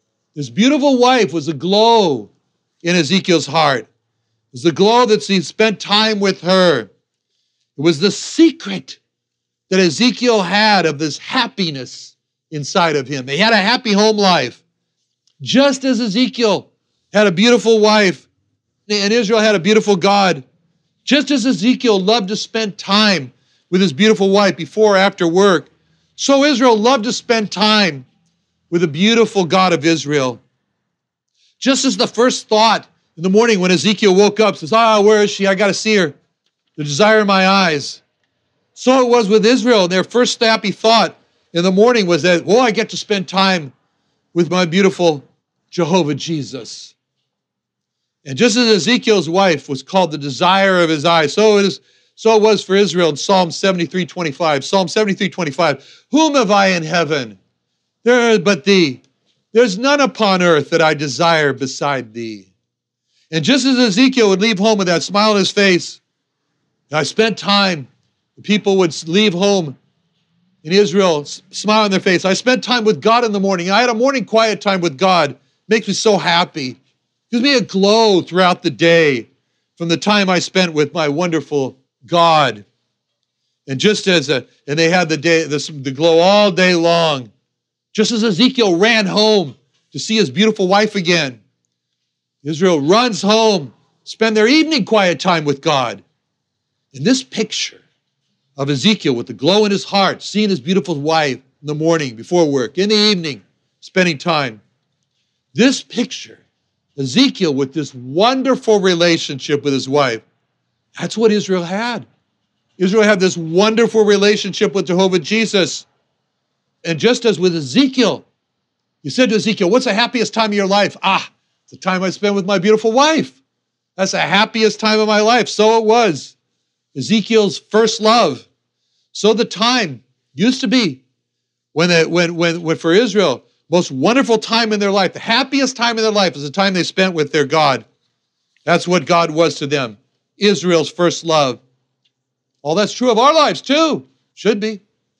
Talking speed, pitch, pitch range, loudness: 170 wpm, 190 Hz, 160-215 Hz, -14 LUFS